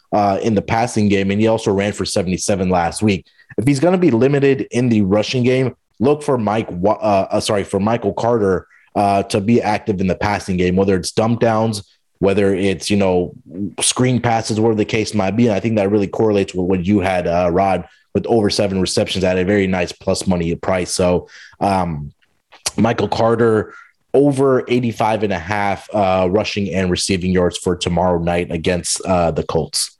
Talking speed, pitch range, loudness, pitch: 200 wpm, 95-115 Hz, -17 LUFS, 100 Hz